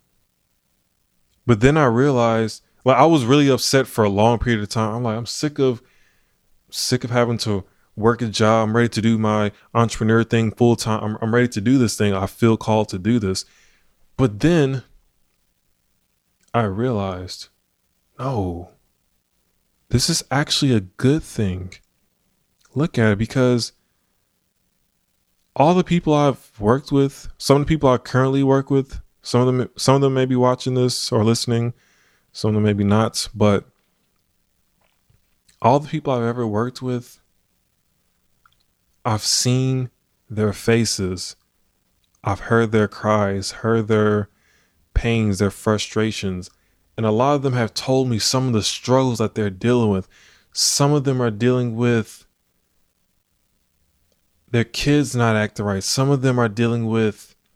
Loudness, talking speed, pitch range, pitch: -19 LUFS, 155 wpm, 100-125 Hz, 115 Hz